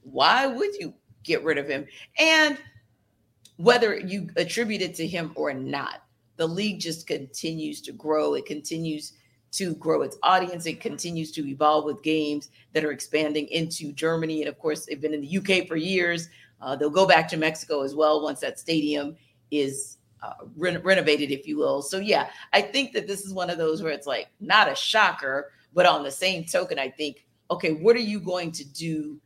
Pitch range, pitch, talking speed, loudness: 145-180 Hz, 155 Hz, 200 wpm, -25 LUFS